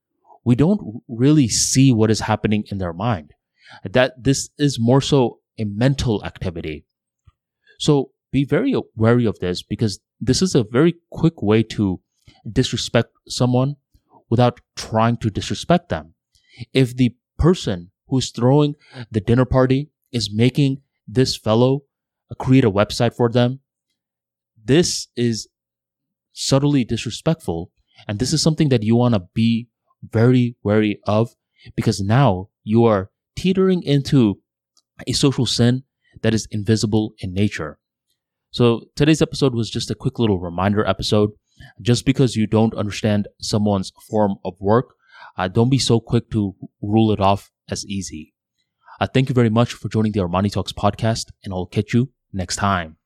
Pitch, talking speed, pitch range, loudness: 115 Hz, 150 wpm, 105-130 Hz, -19 LUFS